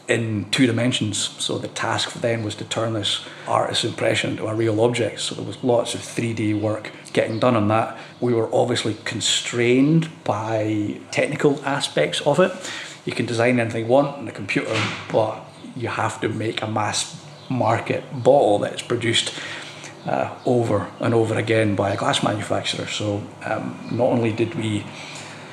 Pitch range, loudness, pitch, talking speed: 110-125 Hz, -22 LUFS, 115 Hz, 170 wpm